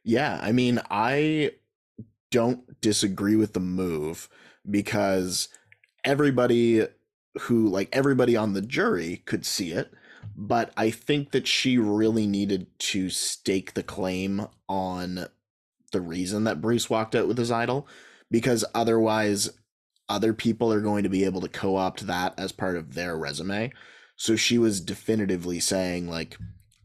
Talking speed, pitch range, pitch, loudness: 145 wpm, 95-115 Hz, 105 Hz, -26 LUFS